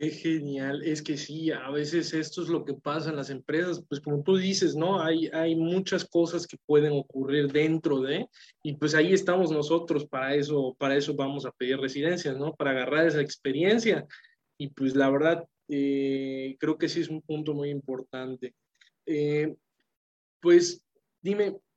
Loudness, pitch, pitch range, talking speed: -28 LUFS, 150 Hz, 140-165 Hz, 175 wpm